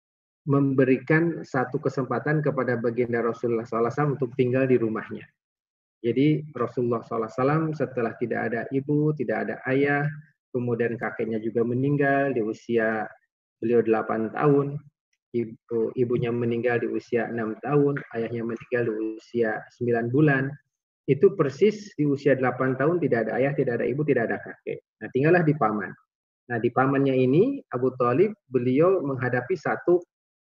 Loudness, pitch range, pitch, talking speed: -25 LUFS, 115-145 Hz, 130 Hz, 135 wpm